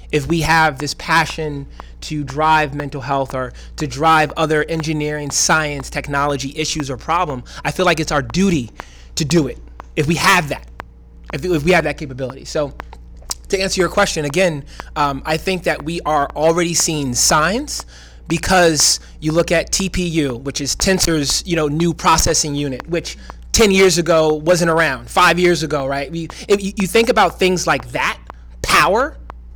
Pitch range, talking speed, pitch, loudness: 140-170 Hz, 170 wpm, 155 Hz, -16 LUFS